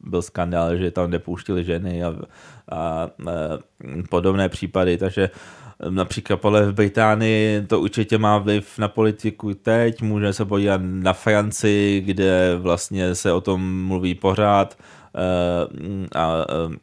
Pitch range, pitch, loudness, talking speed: 90-105 Hz, 95 Hz, -21 LUFS, 130 wpm